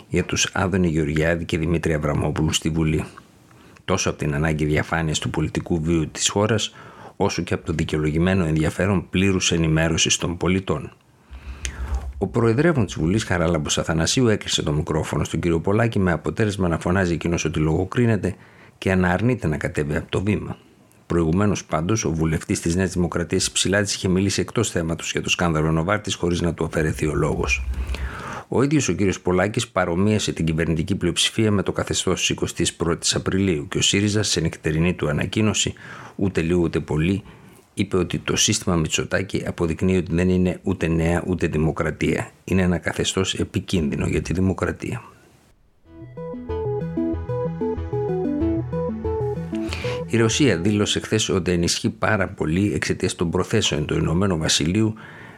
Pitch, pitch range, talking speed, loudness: 90 Hz, 80-100 Hz, 150 wpm, -22 LUFS